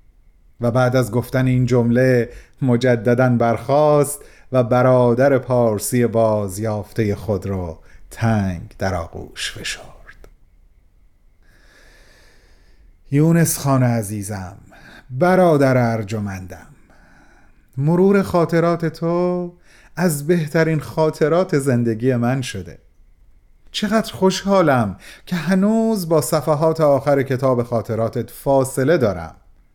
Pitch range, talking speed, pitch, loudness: 105-155 Hz, 90 wpm, 125 Hz, -18 LUFS